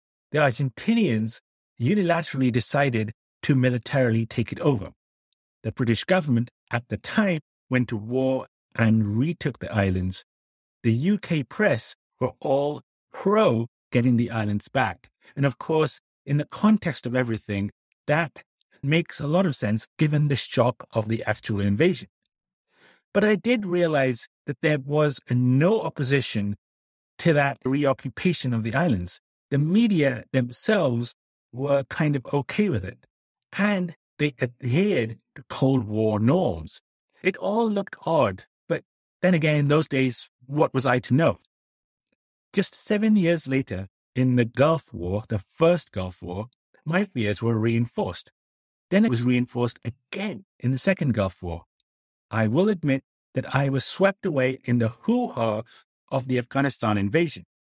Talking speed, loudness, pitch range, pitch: 145 wpm, -24 LUFS, 110-155 Hz, 130 Hz